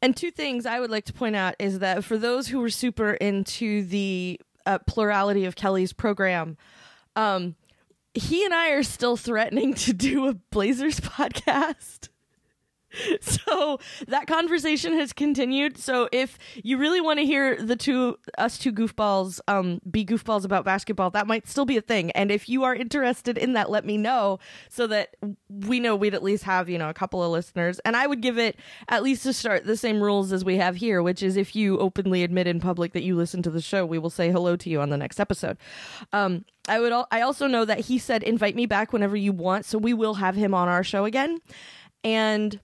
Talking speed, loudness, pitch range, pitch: 215 wpm, -25 LUFS, 190-250 Hz, 215 Hz